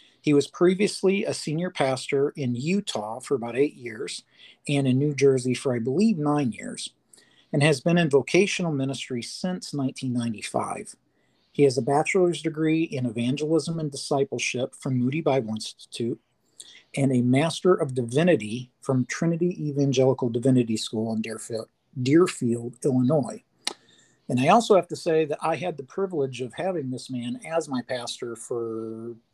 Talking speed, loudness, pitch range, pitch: 155 wpm, -25 LUFS, 125-160 Hz, 135 Hz